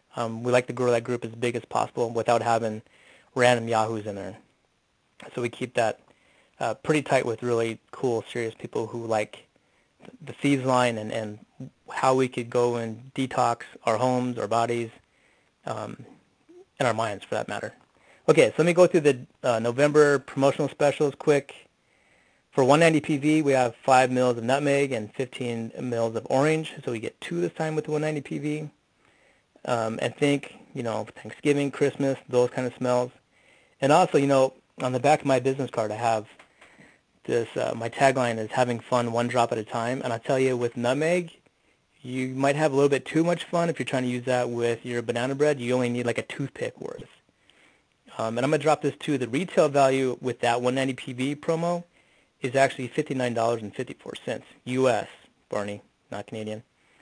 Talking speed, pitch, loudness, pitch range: 190 wpm, 125 Hz, -25 LUFS, 120-140 Hz